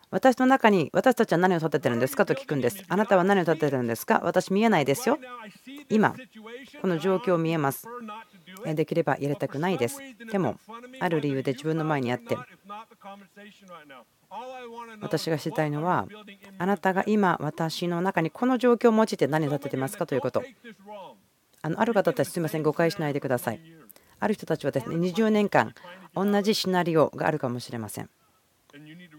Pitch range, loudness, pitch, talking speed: 155-210 Hz, -26 LUFS, 180 Hz, 355 characters per minute